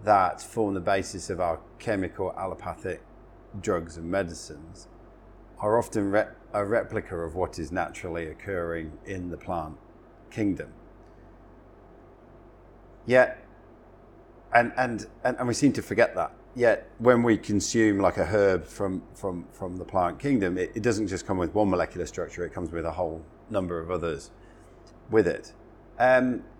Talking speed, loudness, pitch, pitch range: 155 wpm, -27 LUFS, 100 Hz, 85-115 Hz